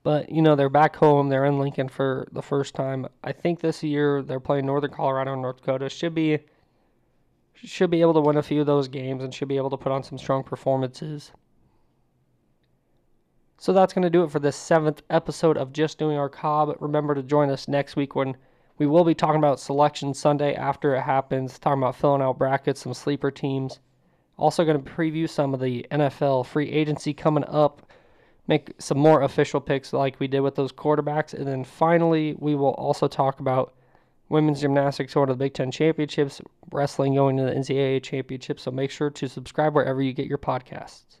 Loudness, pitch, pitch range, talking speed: -24 LUFS, 145 Hz, 135-150 Hz, 200 wpm